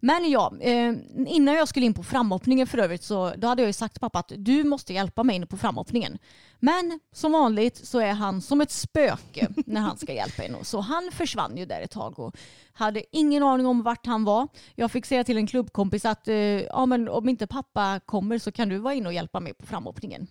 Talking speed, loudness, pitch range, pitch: 225 wpm, -25 LUFS, 210-265 Hz, 240 Hz